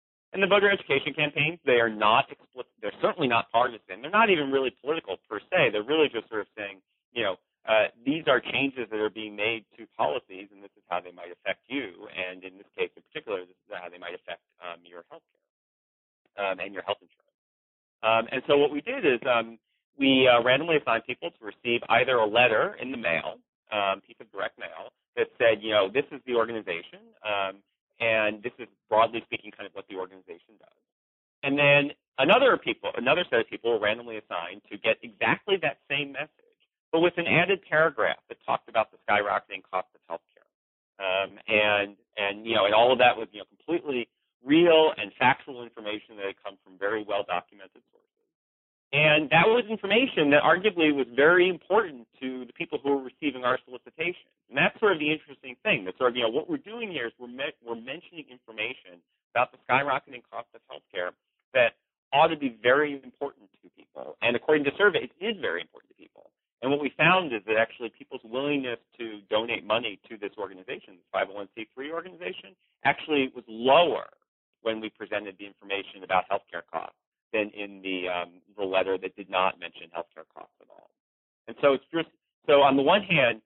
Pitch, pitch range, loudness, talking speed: 125 Hz, 100-150 Hz, -26 LUFS, 205 wpm